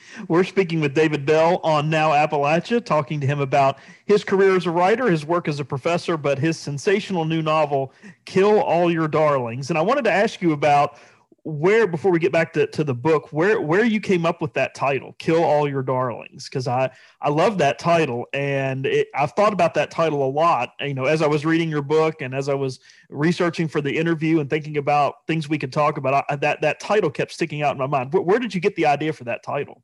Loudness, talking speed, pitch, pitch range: -21 LUFS, 235 wpm, 155 Hz, 145-170 Hz